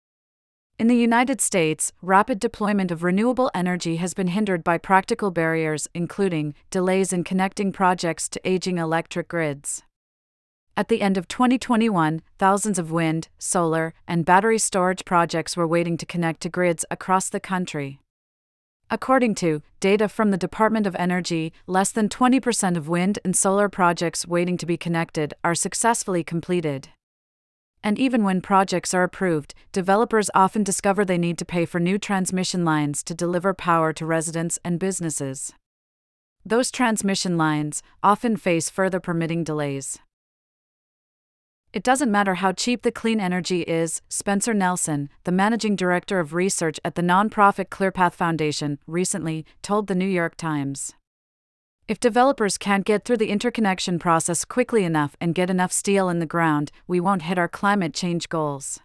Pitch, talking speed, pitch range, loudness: 180 Hz, 155 wpm, 165-200 Hz, -22 LUFS